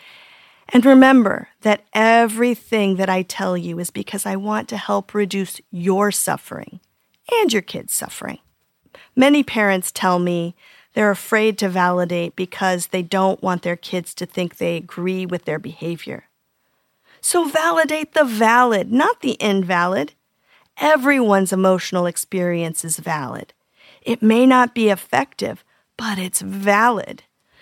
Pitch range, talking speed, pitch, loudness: 180-230 Hz, 135 wpm, 195 Hz, -18 LUFS